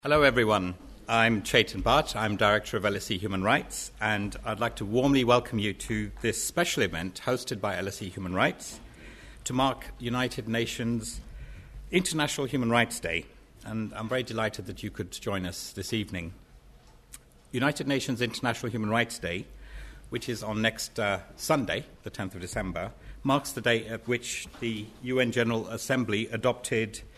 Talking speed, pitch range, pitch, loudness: 160 wpm, 105-125 Hz, 115 Hz, -29 LUFS